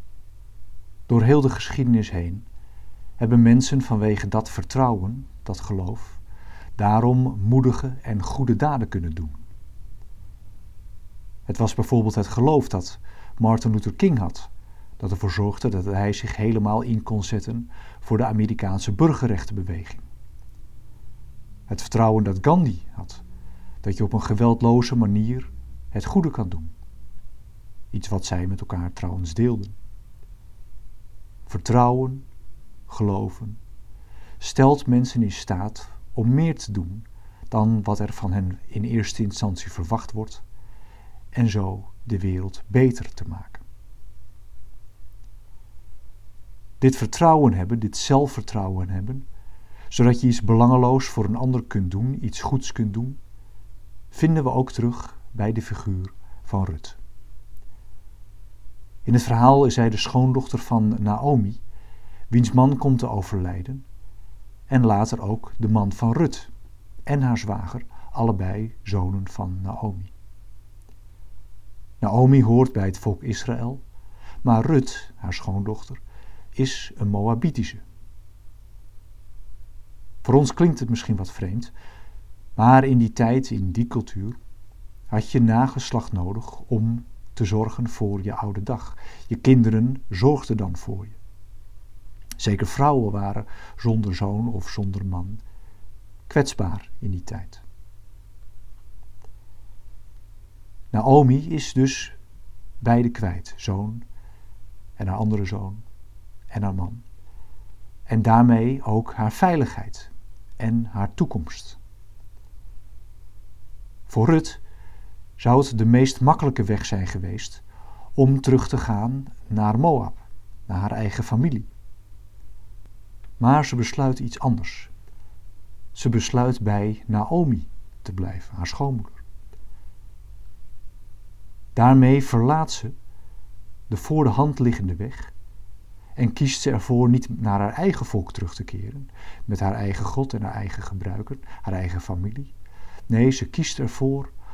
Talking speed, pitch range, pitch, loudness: 120 wpm, 100-115 Hz, 105 Hz, -22 LUFS